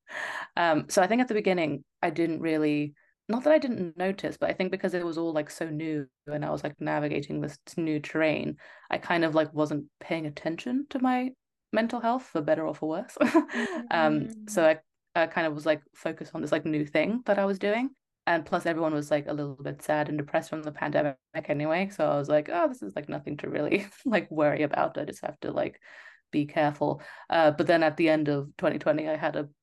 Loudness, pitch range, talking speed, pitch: -28 LUFS, 150-190 Hz, 230 wpm, 160 Hz